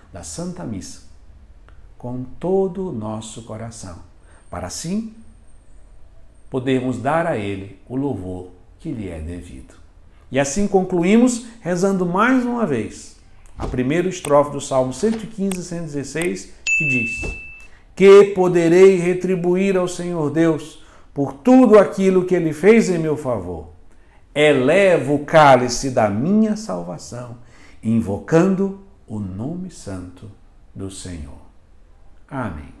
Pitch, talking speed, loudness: 130 Hz, 115 wpm, -18 LUFS